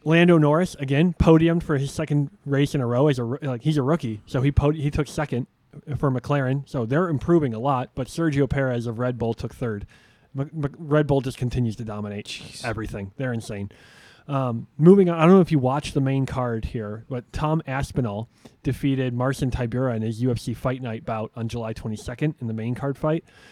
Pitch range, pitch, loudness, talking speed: 120-150 Hz, 135 Hz, -23 LUFS, 210 wpm